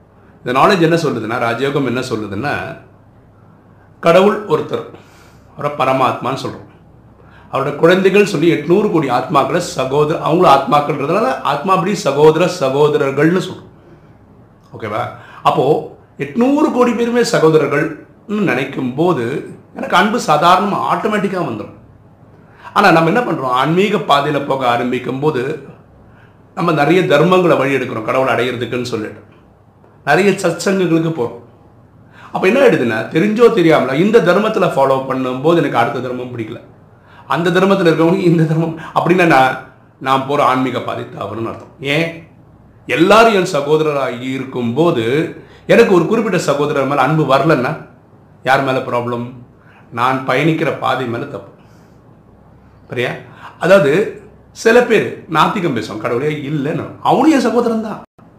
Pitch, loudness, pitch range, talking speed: 145 Hz, -14 LUFS, 125-175 Hz, 120 wpm